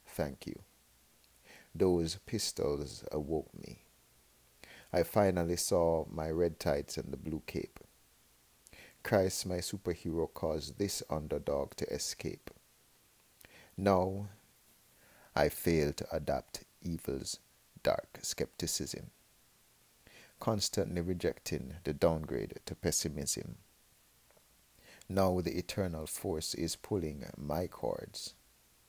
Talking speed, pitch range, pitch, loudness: 95 wpm, 80-100 Hz, 90 Hz, -35 LUFS